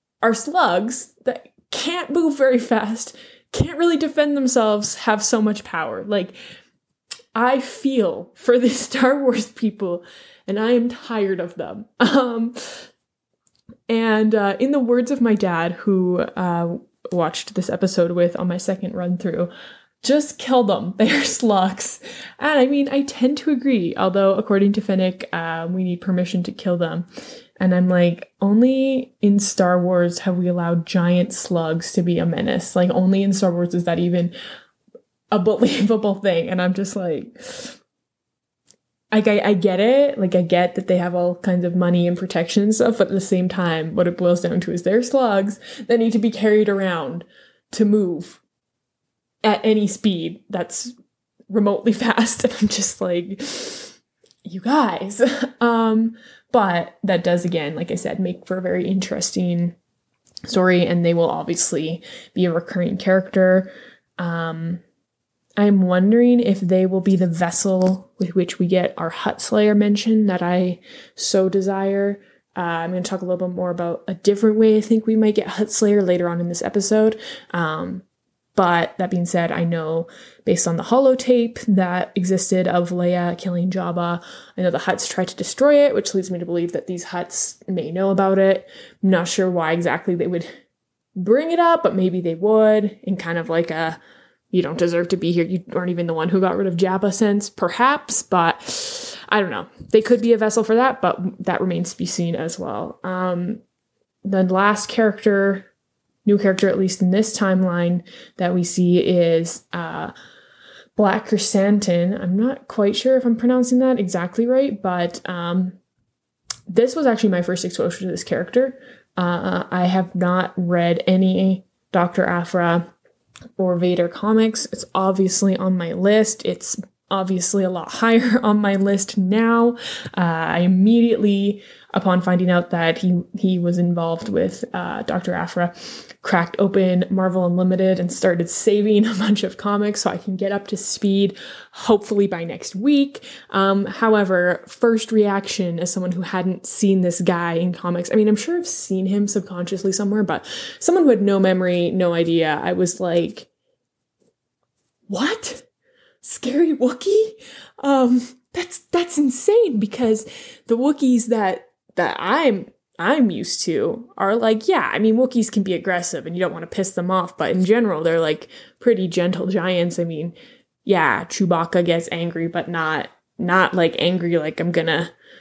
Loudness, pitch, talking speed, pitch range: -19 LUFS, 195 Hz, 175 wpm, 180-225 Hz